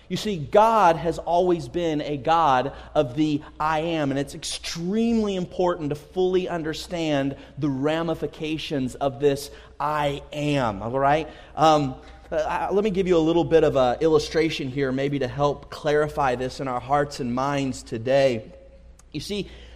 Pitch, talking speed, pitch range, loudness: 150 Hz, 160 wpm, 140-165 Hz, -24 LUFS